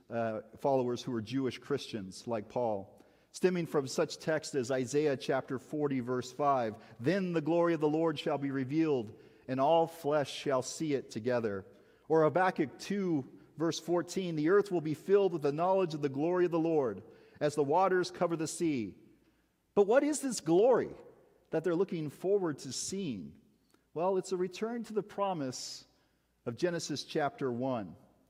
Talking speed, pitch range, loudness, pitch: 170 wpm, 130-180 Hz, -33 LUFS, 155 Hz